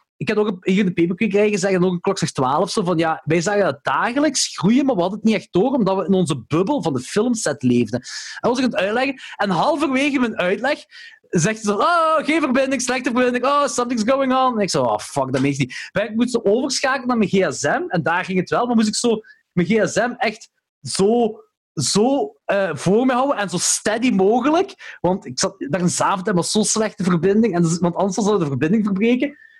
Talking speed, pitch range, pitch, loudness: 225 wpm, 185-255 Hz, 210 Hz, -19 LUFS